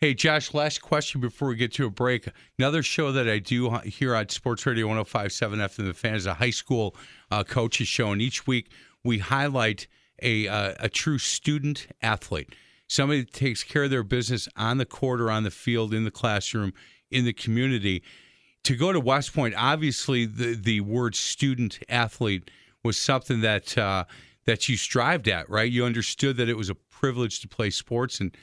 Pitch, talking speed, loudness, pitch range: 120 Hz, 195 wpm, -26 LUFS, 110-135 Hz